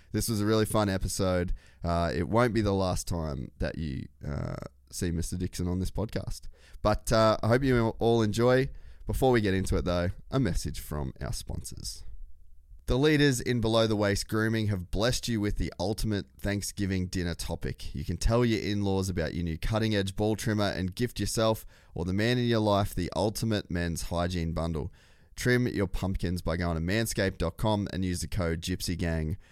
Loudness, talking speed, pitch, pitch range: -29 LUFS, 195 wpm, 95 Hz, 85-110 Hz